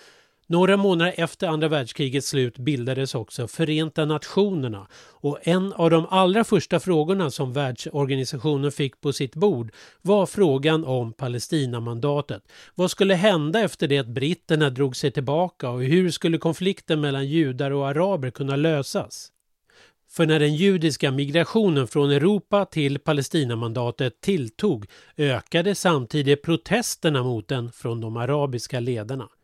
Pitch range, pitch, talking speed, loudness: 135-175 Hz, 150 Hz, 135 wpm, -23 LUFS